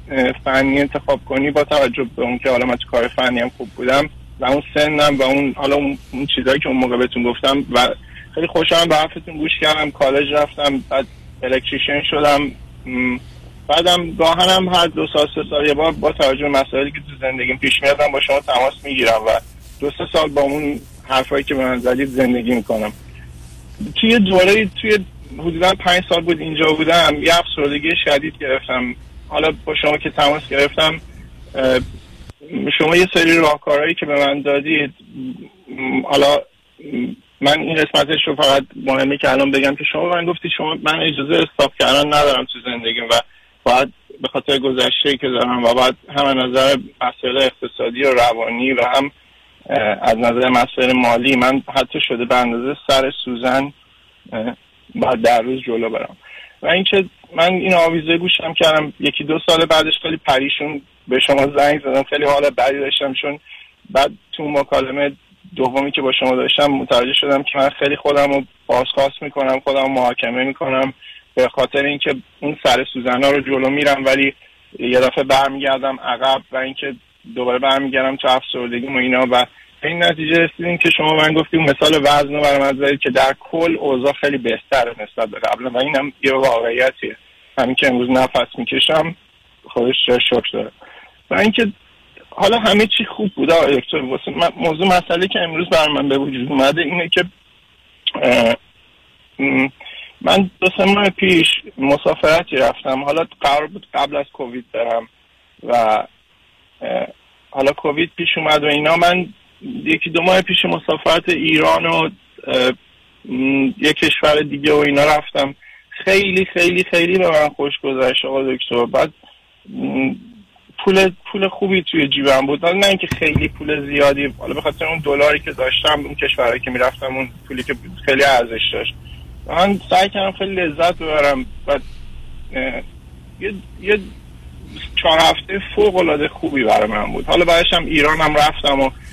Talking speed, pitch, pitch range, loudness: 160 wpm, 140 Hz, 130-160 Hz, -16 LUFS